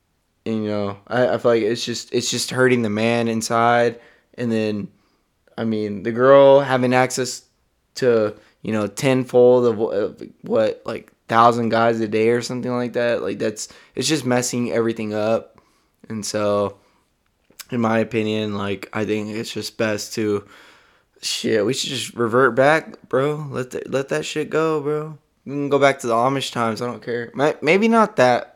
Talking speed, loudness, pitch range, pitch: 180 wpm, -20 LUFS, 110-130 Hz, 120 Hz